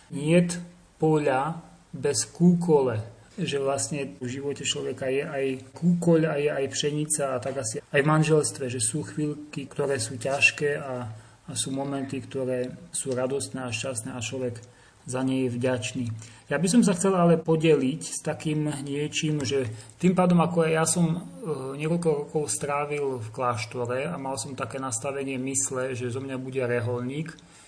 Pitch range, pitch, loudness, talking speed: 130-155 Hz, 140 Hz, -26 LUFS, 165 wpm